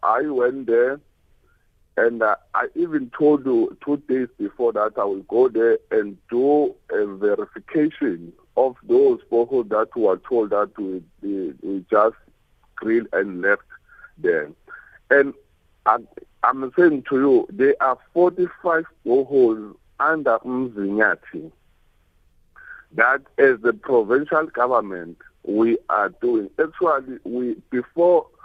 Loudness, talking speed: -21 LUFS, 125 wpm